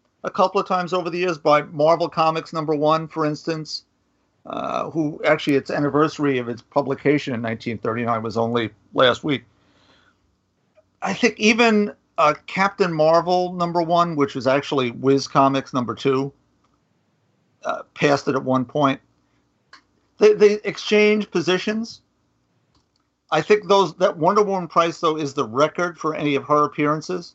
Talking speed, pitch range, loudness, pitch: 150 wpm, 135-180 Hz, -20 LUFS, 155 Hz